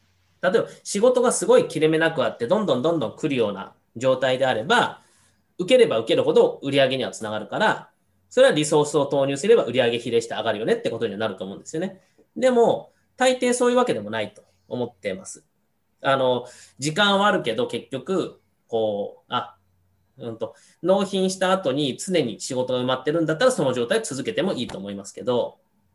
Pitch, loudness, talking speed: 155 Hz, -22 LUFS, 400 characters per minute